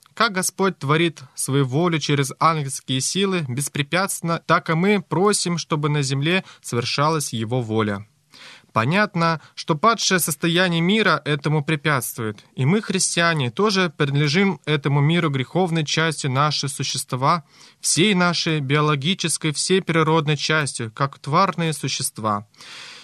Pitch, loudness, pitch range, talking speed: 155 Hz, -20 LUFS, 140-175 Hz, 120 wpm